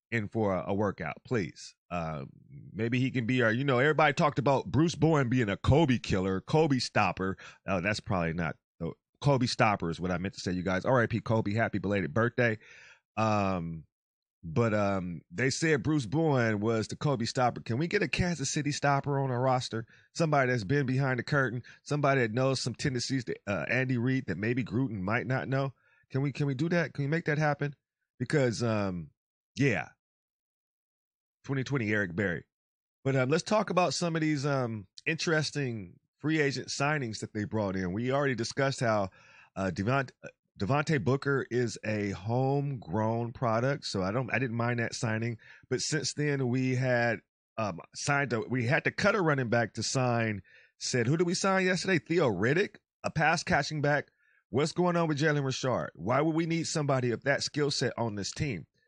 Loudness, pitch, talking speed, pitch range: -30 LUFS, 130 Hz, 190 wpm, 110-145 Hz